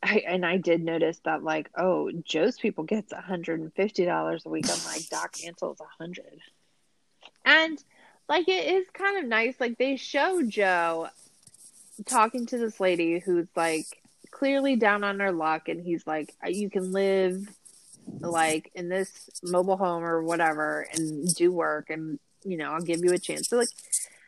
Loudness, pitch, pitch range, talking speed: -27 LUFS, 180 Hz, 165-220 Hz, 165 wpm